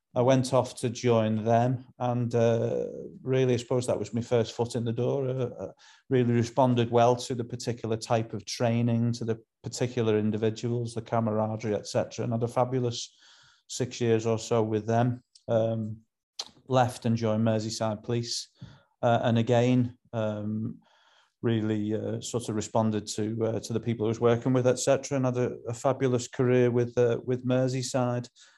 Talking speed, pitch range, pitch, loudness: 170 wpm, 115-125 Hz, 120 Hz, -28 LUFS